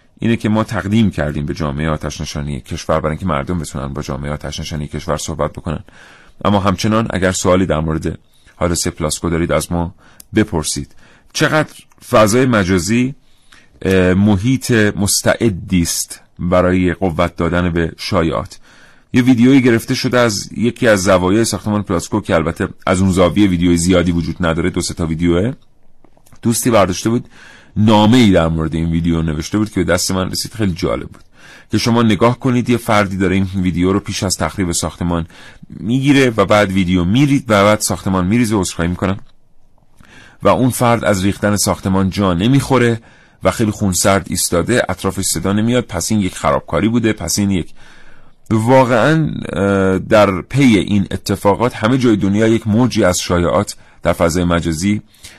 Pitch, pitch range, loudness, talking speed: 95 Hz, 85-110 Hz, -15 LUFS, 160 wpm